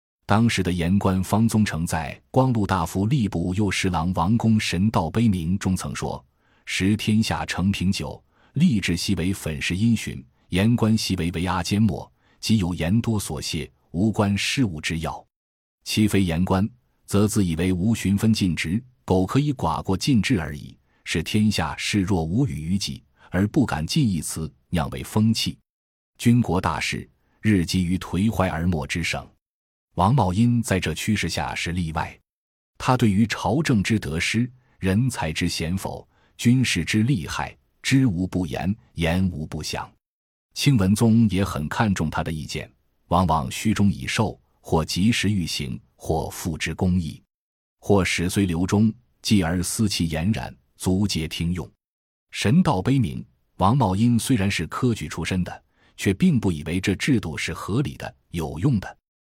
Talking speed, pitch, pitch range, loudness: 225 characters per minute, 95 Hz, 85-110 Hz, -23 LUFS